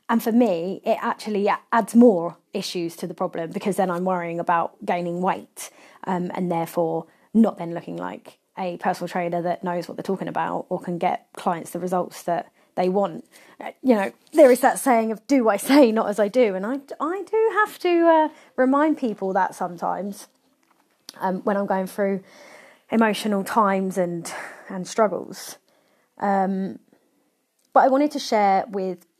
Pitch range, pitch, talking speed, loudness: 180-240 Hz, 195 Hz, 175 wpm, -22 LUFS